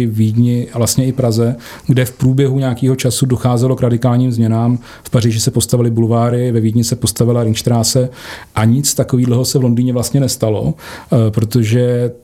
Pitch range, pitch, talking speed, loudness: 115-125 Hz, 120 Hz, 165 wpm, -14 LUFS